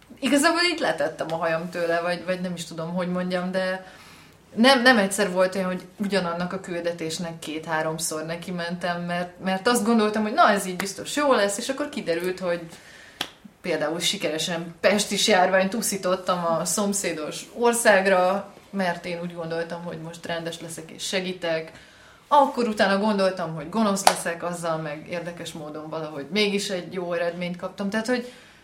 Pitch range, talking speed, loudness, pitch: 170-200 Hz, 160 wpm, -24 LUFS, 180 Hz